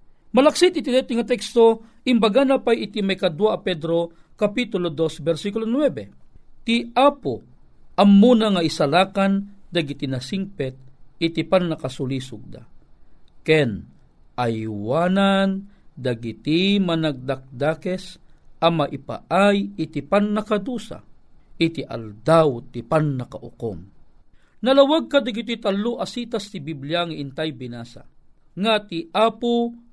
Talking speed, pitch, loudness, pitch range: 105 wpm, 175 Hz, -21 LUFS, 140-220 Hz